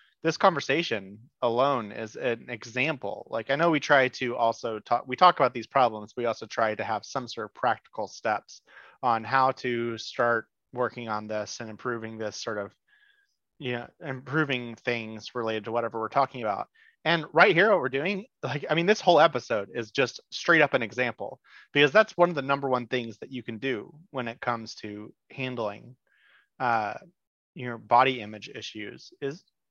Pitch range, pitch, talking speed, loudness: 115-140 Hz, 125 Hz, 190 wpm, -27 LUFS